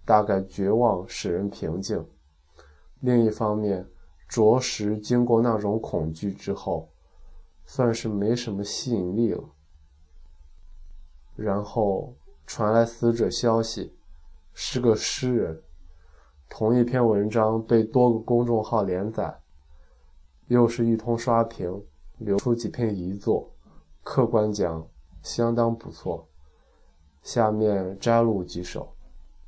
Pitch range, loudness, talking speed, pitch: 75-115 Hz, -25 LUFS, 165 characters per minute, 100 Hz